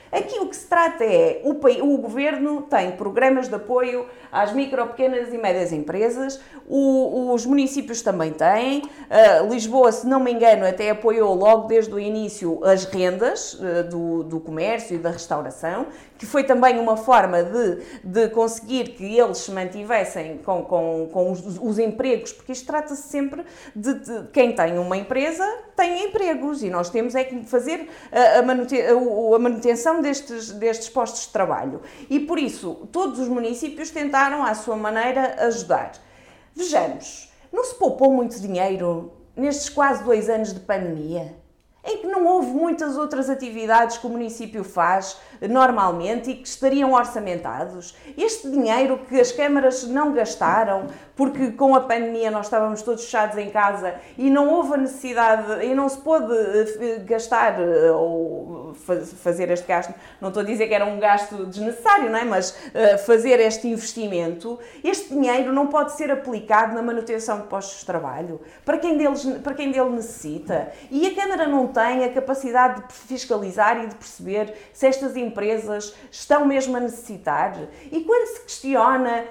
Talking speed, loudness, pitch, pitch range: 165 wpm, -21 LUFS, 235 Hz, 210-275 Hz